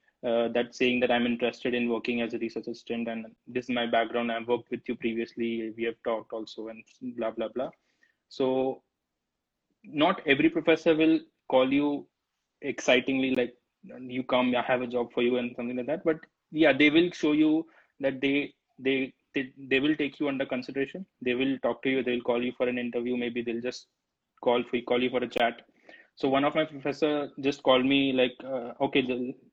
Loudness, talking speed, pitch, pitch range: -28 LUFS, 205 wpm, 125 Hz, 120-140 Hz